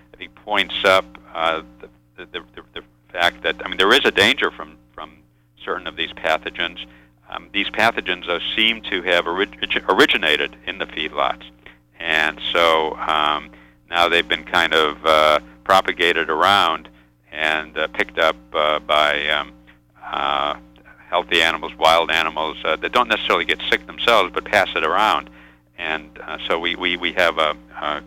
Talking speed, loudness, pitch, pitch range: 165 wpm, -18 LUFS, 75 Hz, 60-80 Hz